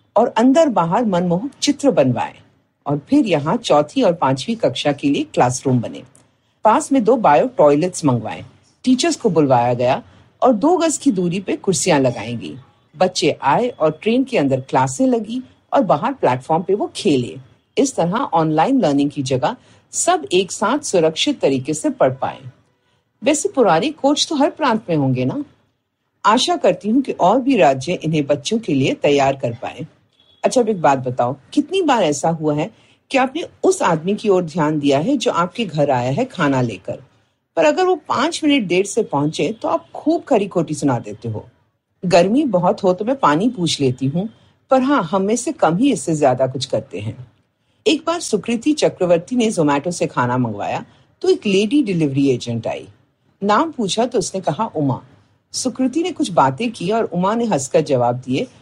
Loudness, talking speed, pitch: -17 LUFS, 155 wpm, 175 Hz